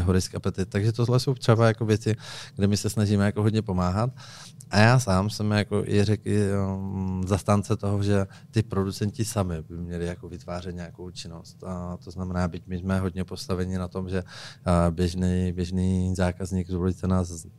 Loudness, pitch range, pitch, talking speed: -26 LUFS, 90-105 Hz, 95 Hz, 175 wpm